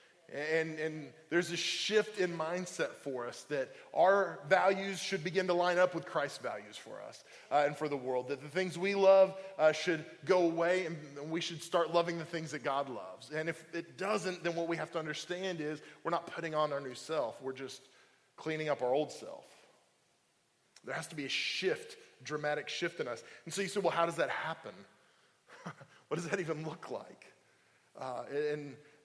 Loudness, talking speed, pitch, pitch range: -34 LUFS, 205 wpm, 165 Hz, 150-185 Hz